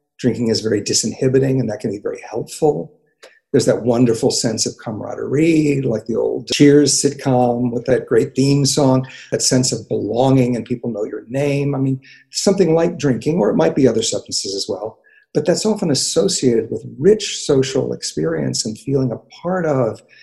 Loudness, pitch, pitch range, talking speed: -17 LUFS, 135 Hz, 125-150 Hz, 180 wpm